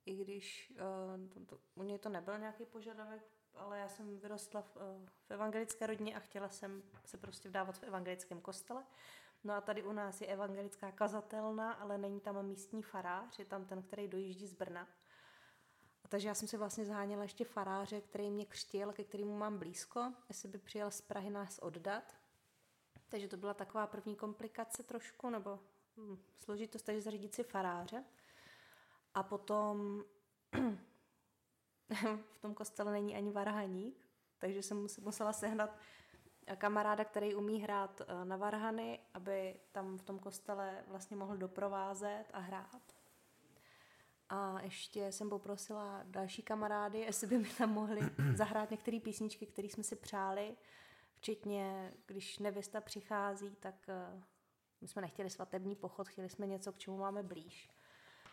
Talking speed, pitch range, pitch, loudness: 155 wpm, 195-215 Hz, 205 Hz, -44 LUFS